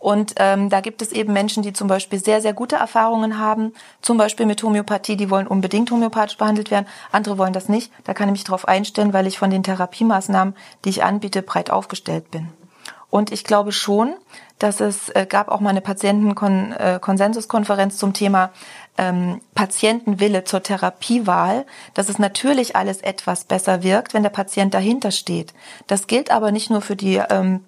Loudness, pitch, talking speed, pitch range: -19 LUFS, 205 Hz, 180 wpm, 195-215 Hz